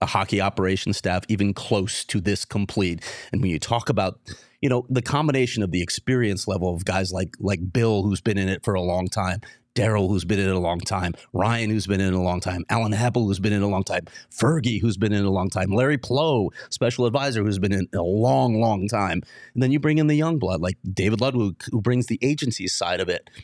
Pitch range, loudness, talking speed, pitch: 95-120 Hz, -23 LUFS, 250 wpm, 105 Hz